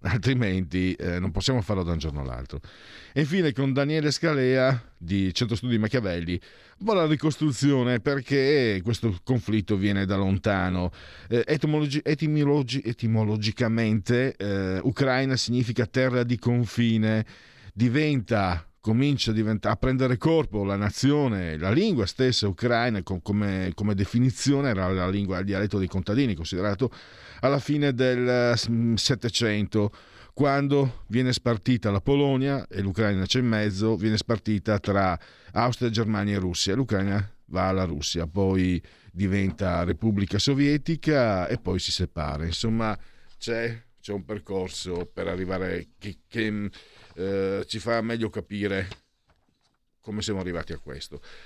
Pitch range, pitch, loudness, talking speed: 95-125 Hz, 110 Hz, -25 LUFS, 130 wpm